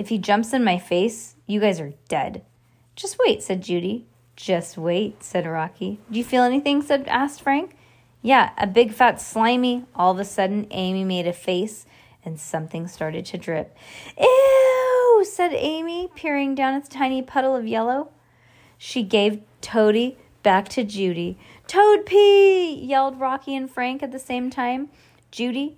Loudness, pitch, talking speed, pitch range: -21 LUFS, 240 Hz, 165 wpm, 185-275 Hz